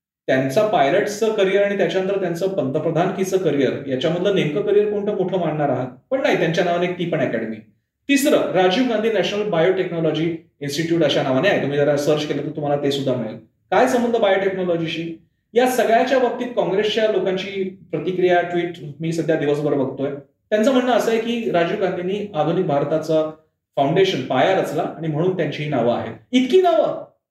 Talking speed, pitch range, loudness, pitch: 165 wpm, 150-200 Hz, -20 LUFS, 175 Hz